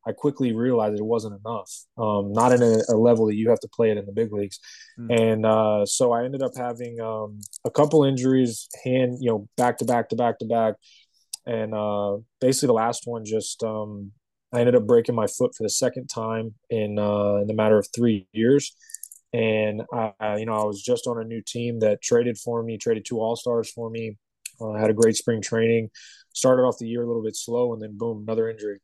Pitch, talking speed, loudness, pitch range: 115 Hz, 230 wpm, -23 LUFS, 110-120 Hz